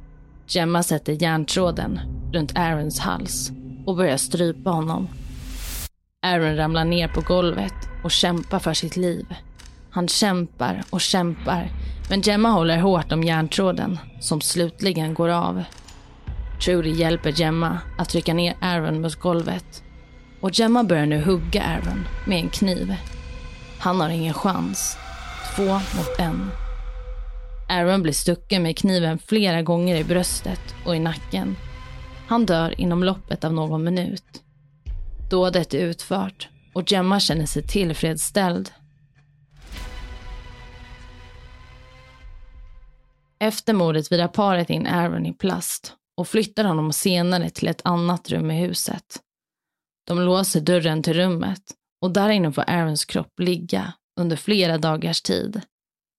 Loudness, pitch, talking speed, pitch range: -22 LUFS, 170 Hz, 130 wpm, 150-180 Hz